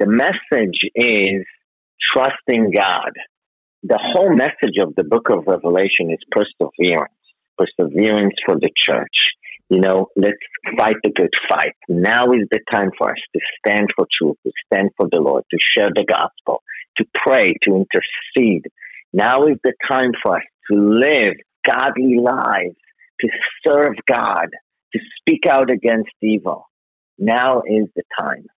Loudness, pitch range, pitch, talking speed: -16 LUFS, 100-125 Hz, 110 Hz, 150 wpm